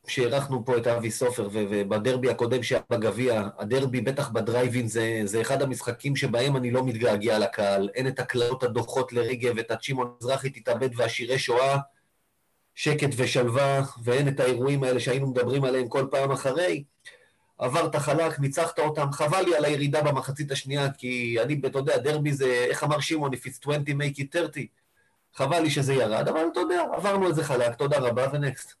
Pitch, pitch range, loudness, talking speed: 135 Hz, 125-145 Hz, -26 LUFS, 175 wpm